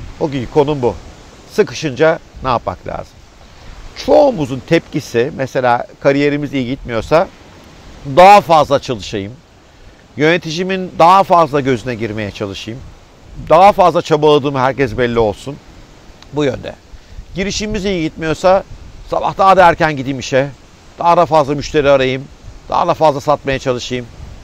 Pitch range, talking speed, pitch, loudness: 125-165 Hz, 125 wpm, 145 Hz, -13 LUFS